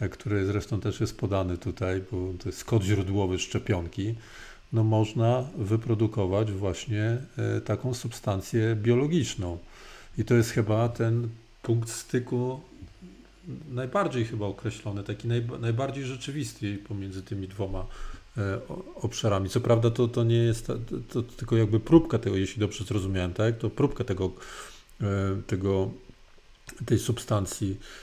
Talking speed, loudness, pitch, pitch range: 125 wpm, -28 LUFS, 110 Hz, 100-120 Hz